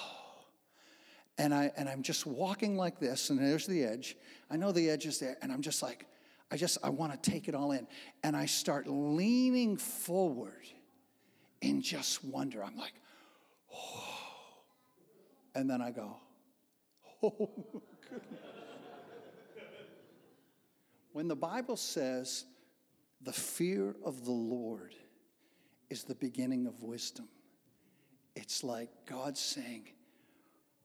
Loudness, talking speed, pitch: -36 LUFS, 130 wpm, 185 Hz